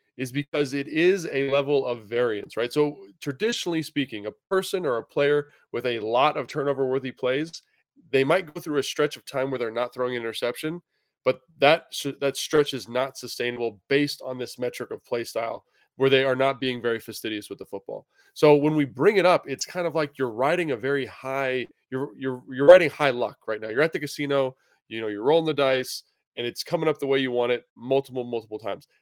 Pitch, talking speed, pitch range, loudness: 135 Hz, 220 wpm, 125-145 Hz, -25 LUFS